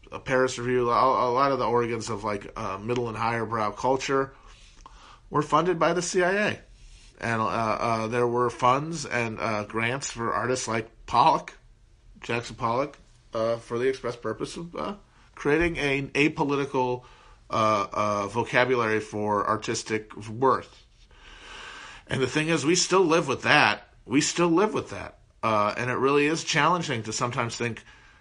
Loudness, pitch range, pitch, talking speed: -25 LUFS, 110-135 Hz, 120 Hz, 160 wpm